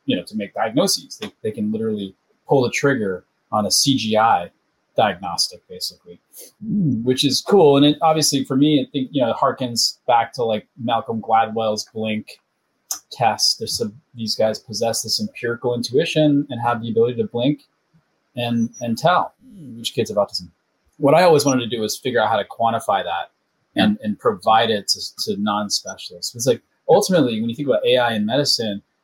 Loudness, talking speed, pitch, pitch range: -19 LUFS, 185 wpm, 120 Hz, 110-140 Hz